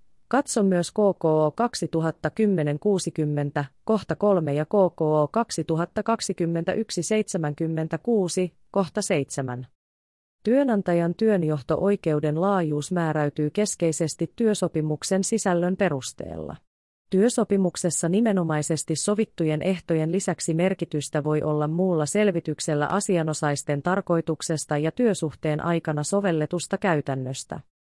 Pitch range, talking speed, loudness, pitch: 155-195 Hz, 80 wpm, -24 LUFS, 170 Hz